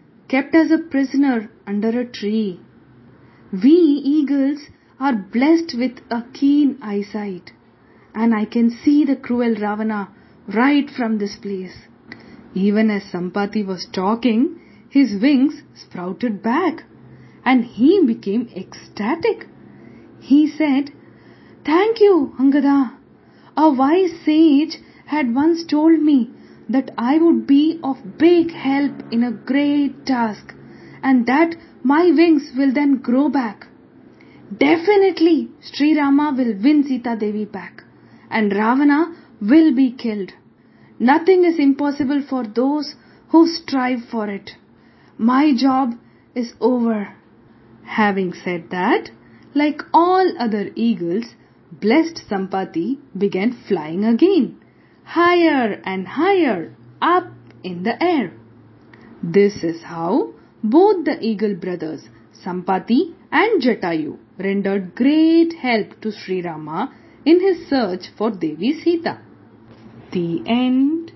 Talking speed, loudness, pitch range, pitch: 115 wpm, -18 LUFS, 205-295 Hz, 250 Hz